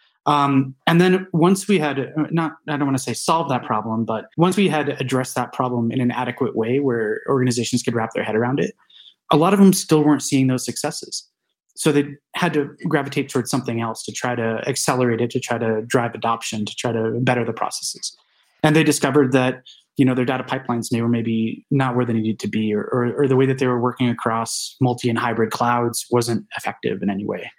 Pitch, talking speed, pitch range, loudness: 125 Hz, 220 wpm, 120-145 Hz, -20 LUFS